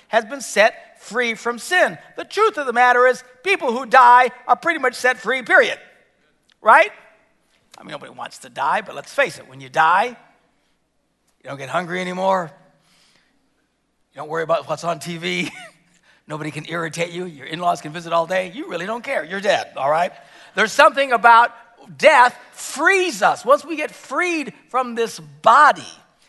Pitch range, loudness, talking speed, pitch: 170-260 Hz, -18 LUFS, 180 wpm, 235 Hz